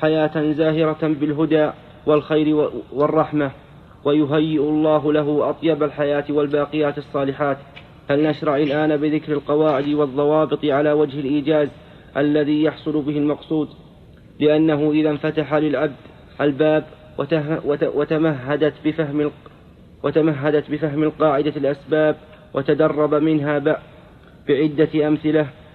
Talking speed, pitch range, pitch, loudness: 85 wpm, 145-155 Hz, 150 Hz, -20 LUFS